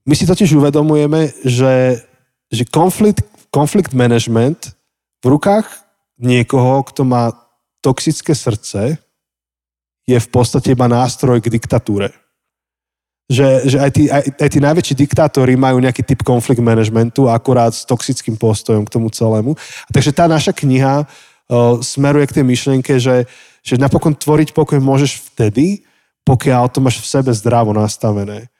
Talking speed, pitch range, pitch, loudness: 140 wpm, 120-145 Hz, 130 Hz, -13 LUFS